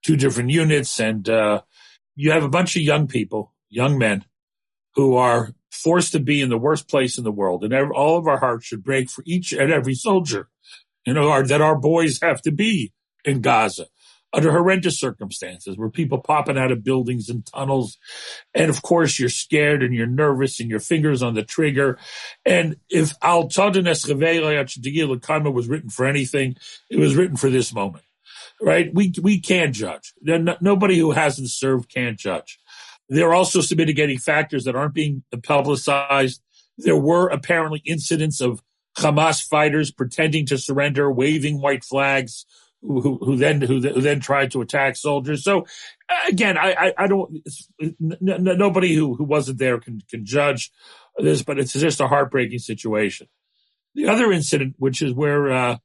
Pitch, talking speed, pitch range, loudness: 145 Hz, 175 wpm, 130-160 Hz, -20 LUFS